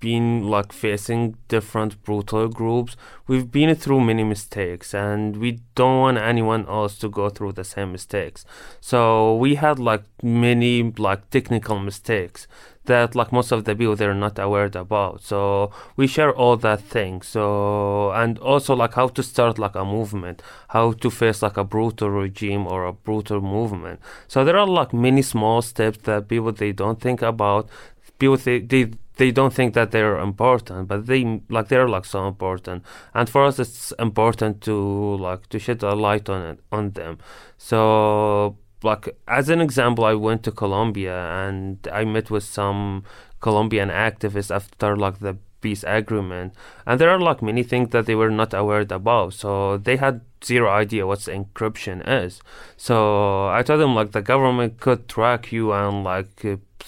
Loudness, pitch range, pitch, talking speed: -21 LUFS, 100-120 Hz, 110 Hz, 175 wpm